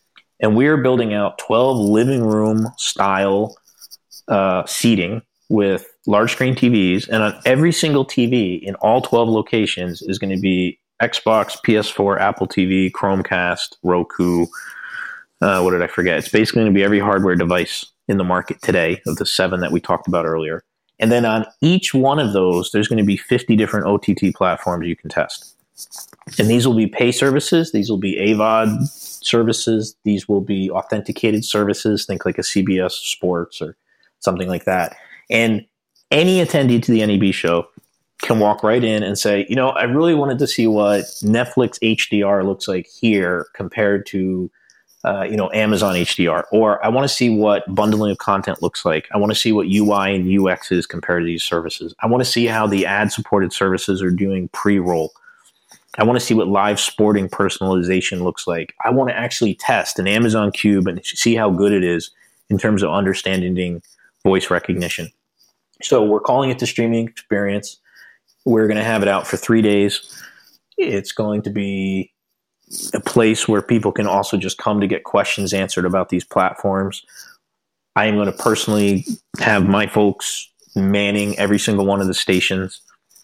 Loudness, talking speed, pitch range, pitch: -17 LUFS, 180 wpm, 95-115 Hz, 105 Hz